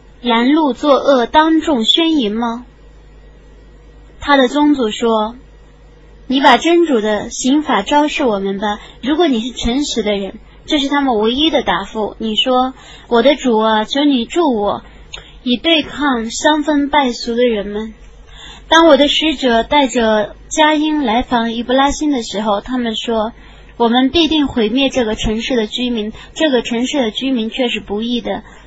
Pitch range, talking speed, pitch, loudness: 225-290 Hz, 230 characters per minute, 250 Hz, -14 LUFS